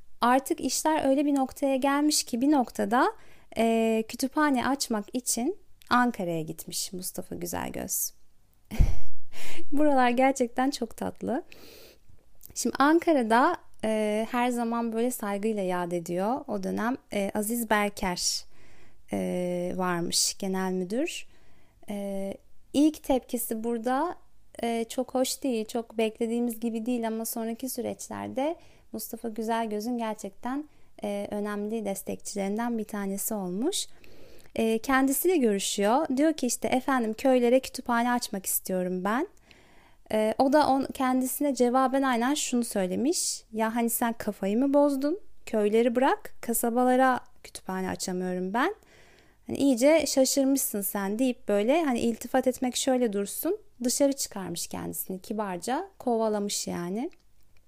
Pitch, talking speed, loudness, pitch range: 235 Hz, 120 wpm, -27 LUFS, 205-270 Hz